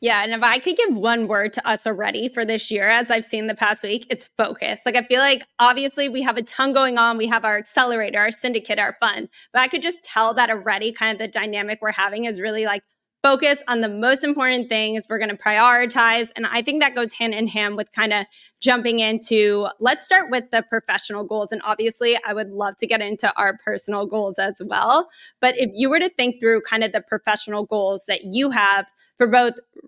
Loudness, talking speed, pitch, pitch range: -20 LUFS, 235 wpm, 225 Hz, 215-250 Hz